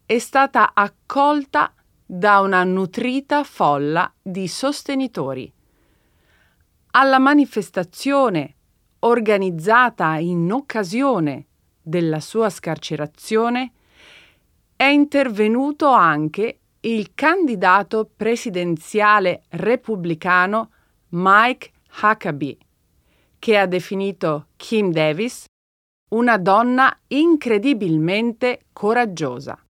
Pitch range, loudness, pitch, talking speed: 160-240 Hz, -18 LUFS, 205 Hz, 70 wpm